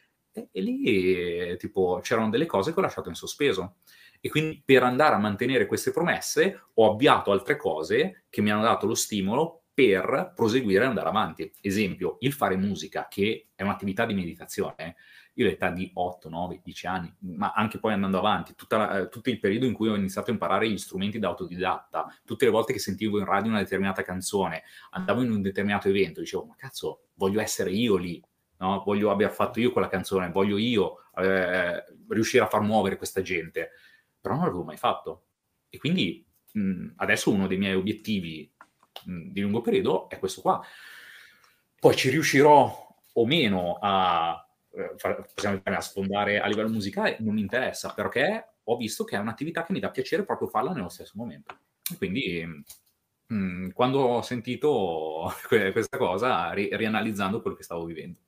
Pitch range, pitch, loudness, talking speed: 95-115 Hz, 100 Hz, -26 LUFS, 180 wpm